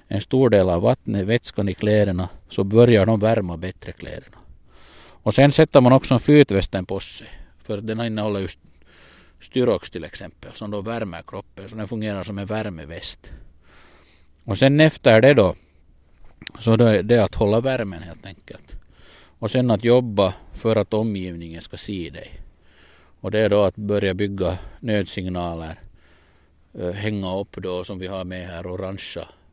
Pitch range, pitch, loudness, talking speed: 85-110 Hz, 95 Hz, -20 LUFS, 165 wpm